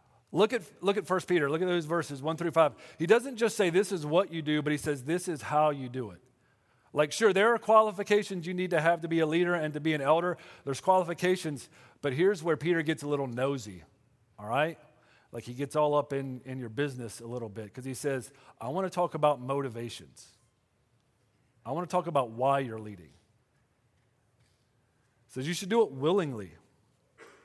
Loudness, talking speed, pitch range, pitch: -29 LUFS, 210 wpm, 125-175 Hz, 145 Hz